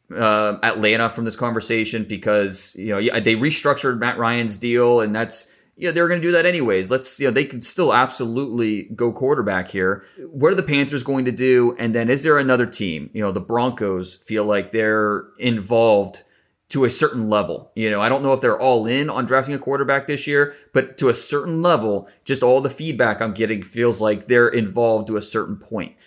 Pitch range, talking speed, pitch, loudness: 110-135 Hz, 210 wpm, 120 Hz, -19 LUFS